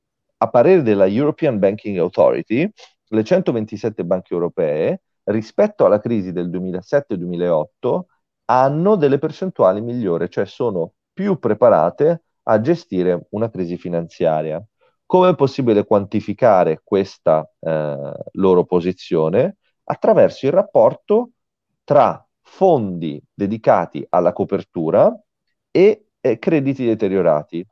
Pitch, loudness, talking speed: 110 Hz, -18 LUFS, 105 wpm